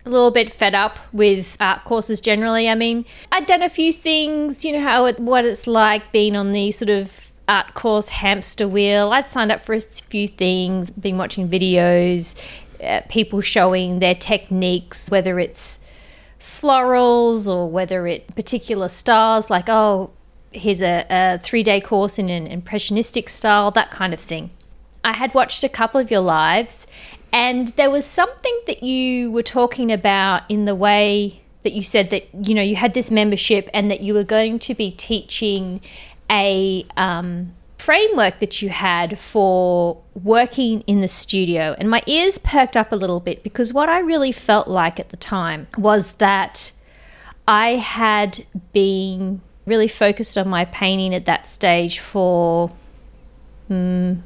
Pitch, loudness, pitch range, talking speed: 205 Hz, -18 LUFS, 185-230 Hz, 170 wpm